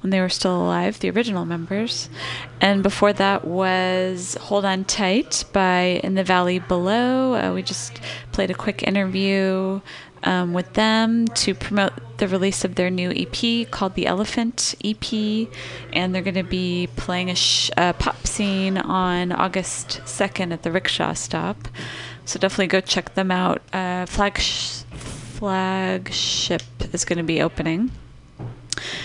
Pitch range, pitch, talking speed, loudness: 175-195 Hz, 185 Hz, 150 wpm, -21 LUFS